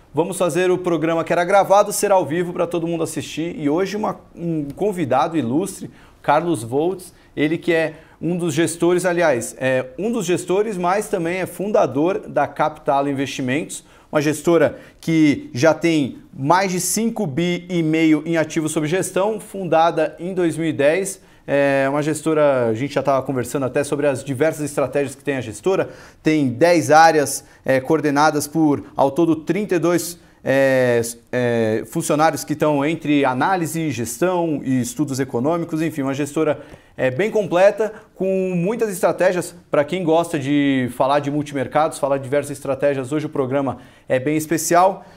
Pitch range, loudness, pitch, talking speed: 140-175 Hz, -19 LUFS, 160 Hz, 160 wpm